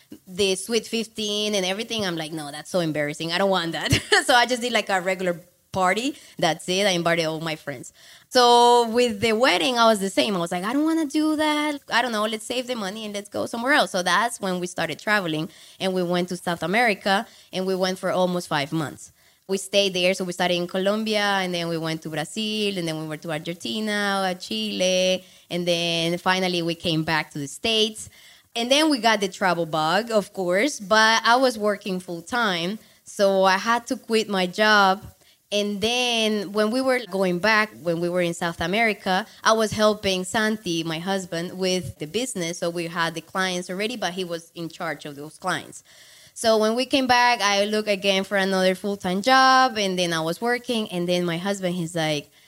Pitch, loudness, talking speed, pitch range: 195 Hz, -22 LUFS, 220 wpm, 175-220 Hz